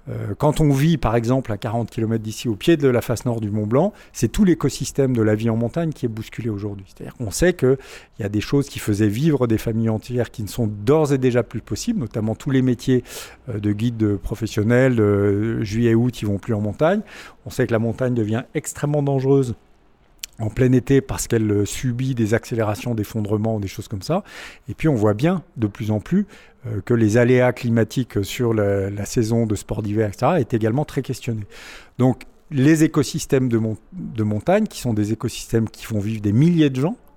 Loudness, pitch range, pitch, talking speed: -21 LUFS, 110-135 Hz, 115 Hz, 210 wpm